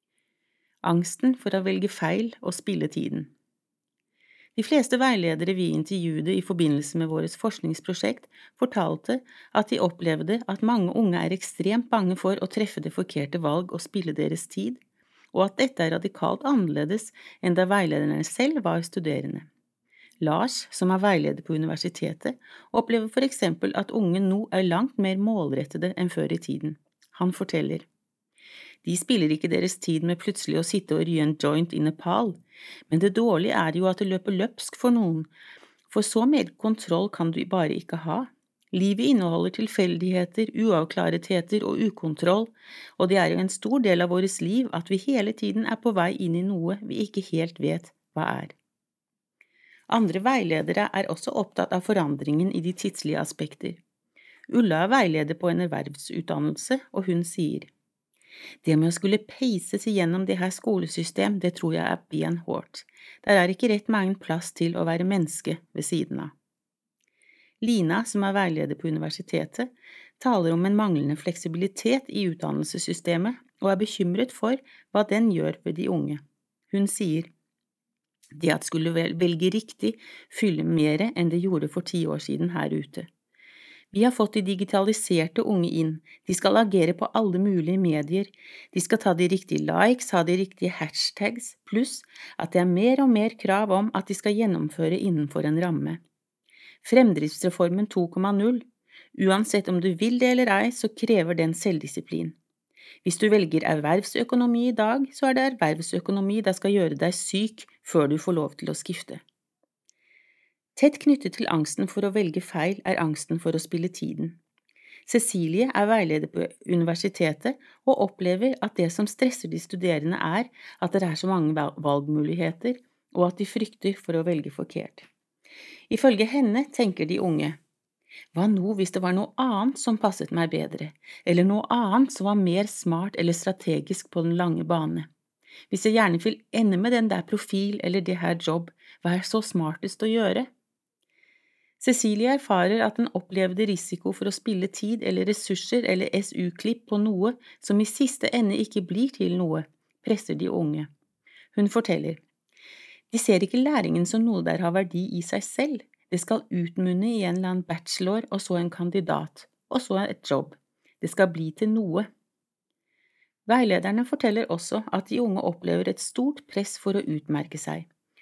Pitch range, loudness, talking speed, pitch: 170-225 Hz, -25 LUFS, 170 wpm, 190 Hz